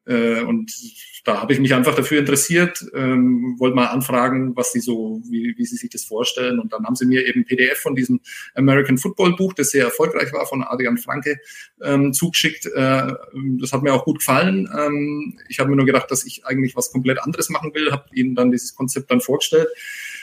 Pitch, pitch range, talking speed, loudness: 135 Hz, 125-160 Hz, 210 wpm, -19 LUFS